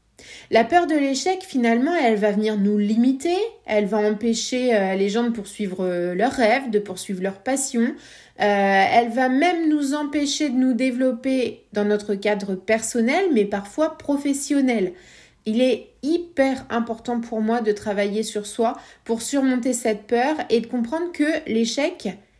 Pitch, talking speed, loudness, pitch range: 235 Hz, 155 wpm, -21 LUFS, 210-275 Hz